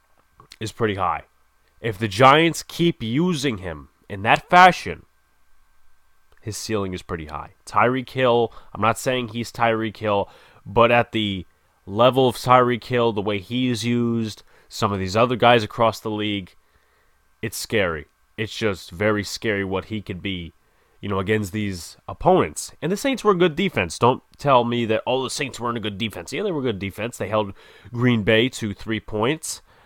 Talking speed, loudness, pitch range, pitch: 185 wpm, -21 LUFS, 95-120 Hz, 110 Hz